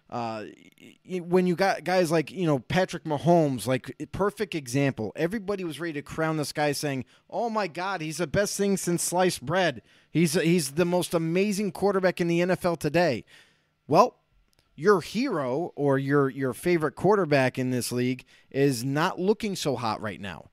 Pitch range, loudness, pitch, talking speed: 140-185 Hz, -26 LUFS, 170 Hz, 175 wpm